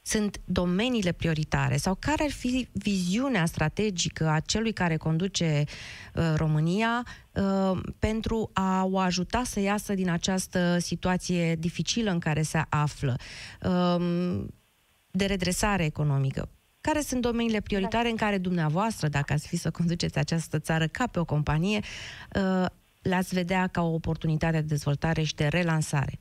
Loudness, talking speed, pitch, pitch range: -28 LUFS, 145 wpm, 175 Hz, 155-195 Hz